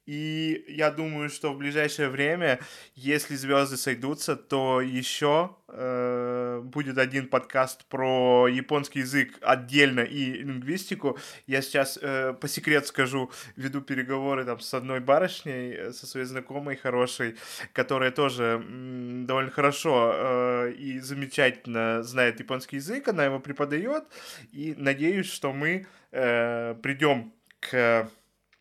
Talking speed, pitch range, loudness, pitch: 125 wpm, 125-145 Hz, -27 LUFS, 135 Hz